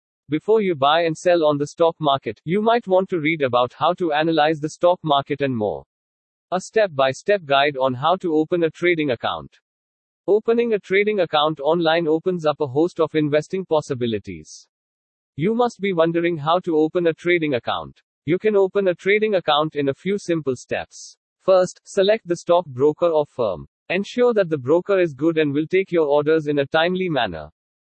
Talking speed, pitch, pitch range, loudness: 195 wpm, 160 Hz, 140-180 Hz, -20 LUFS